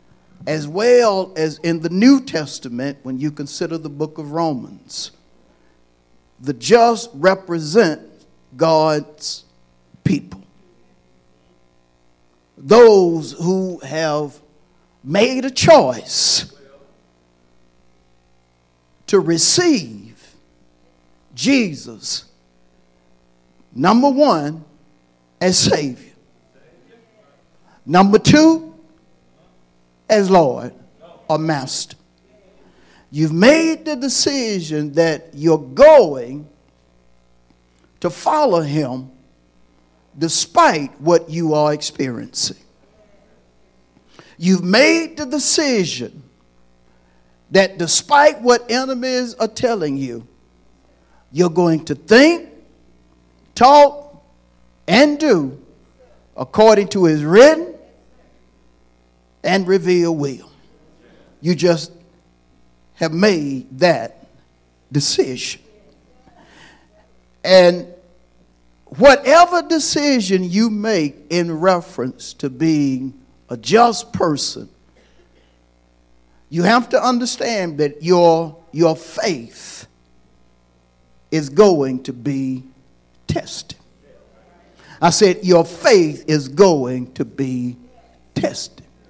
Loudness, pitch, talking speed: -15 LUFS, 150 Hz, 80 wpm